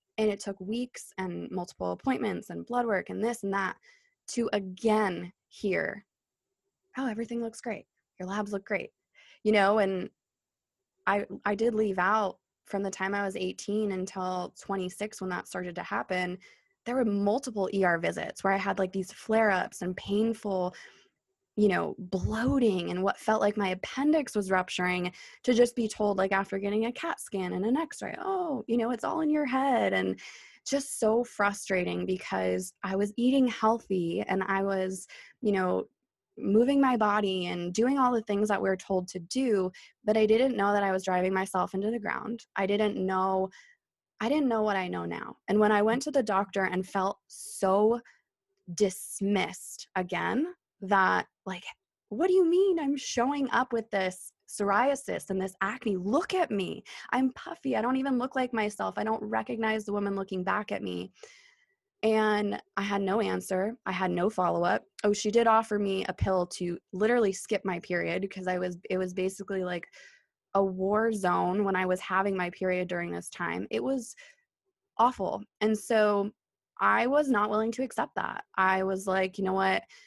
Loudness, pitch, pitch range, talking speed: -29 LUFS, 205 Hz, 190-235 Hz, 185 wpm